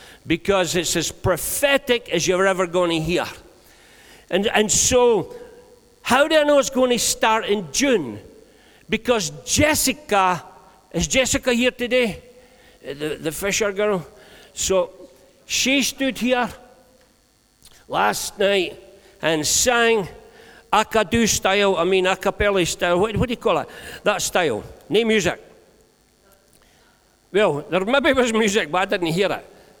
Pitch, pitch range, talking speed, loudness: 210 Hz, 185-250 Hz, 135 wpm, -20 LUFS